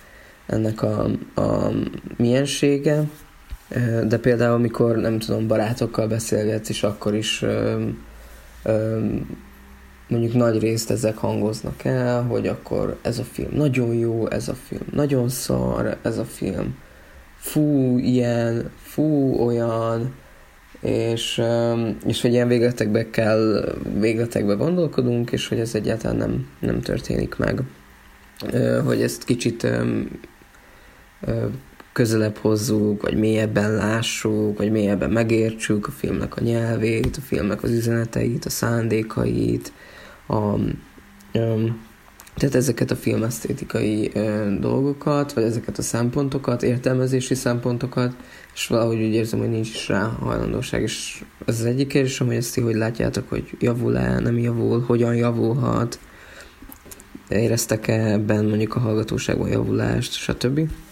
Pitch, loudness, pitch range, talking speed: 115 Hz, -22 LUFS, 105-120 Hz, 125 wpm